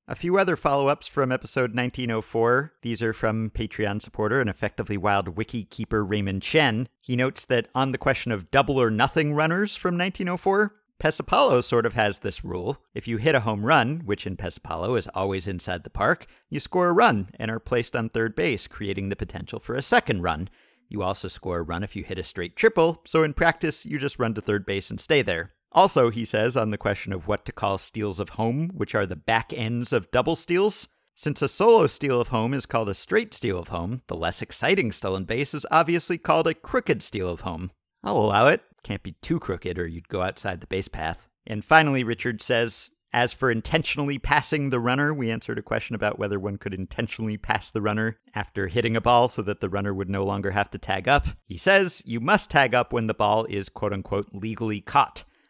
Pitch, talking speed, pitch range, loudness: 115 Hz, 220 wpm, 100-140 Hz, -24 LUFS